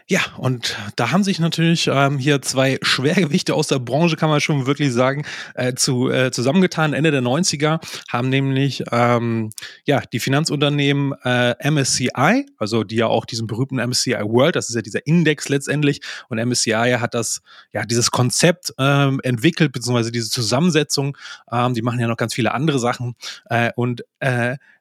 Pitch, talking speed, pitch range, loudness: 135 Hz, 170 wpm, 120-150 Hz, -19 LUFS